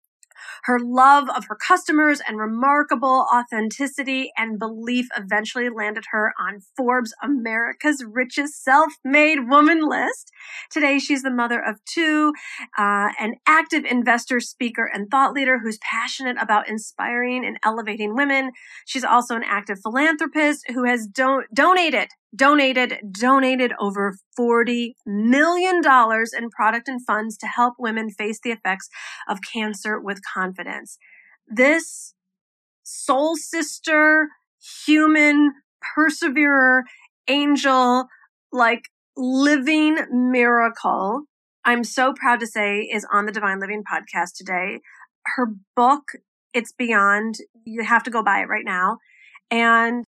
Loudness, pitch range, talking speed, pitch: -20 LUFS, 220-285 Hz, 125 wpm, 245 Hz